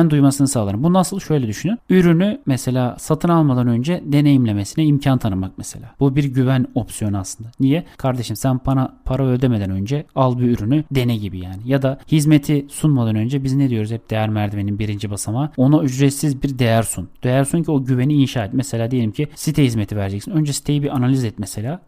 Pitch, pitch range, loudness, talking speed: 130 Hz, 115-145 Hz, -18 LUFS, 195 wpm